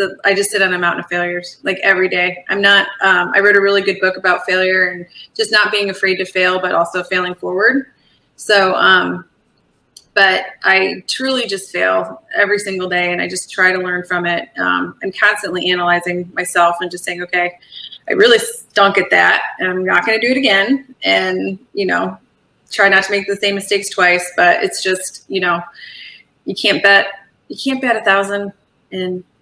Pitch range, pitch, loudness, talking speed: 180-200 Hz, 185 Hz, -14 LUFS, 200 wpm